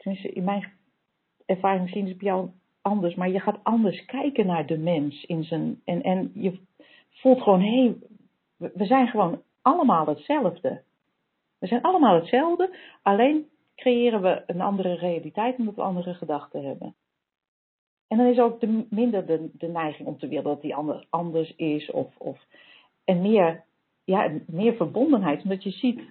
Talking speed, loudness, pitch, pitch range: 170 wpm, -24 LUFS, 195 Hz, 175-235 Hz